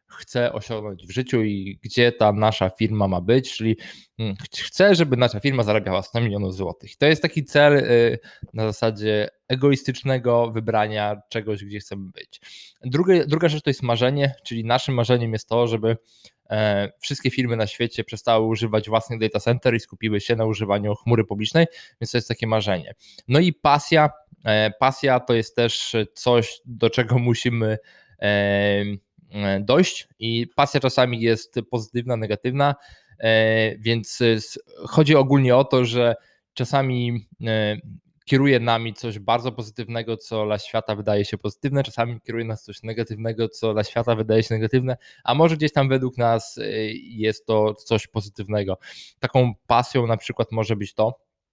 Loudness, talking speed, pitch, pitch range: -22 LUFS, 150 wpm, 115 Hz, 110-125 Hz